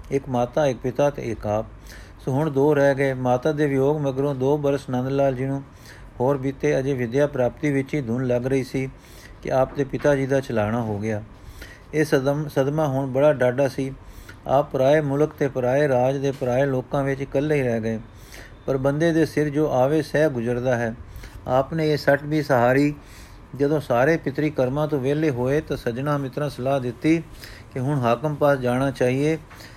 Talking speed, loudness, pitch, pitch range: 190 wpm, -22 LUFS, 135 Hz, 125-145 Hz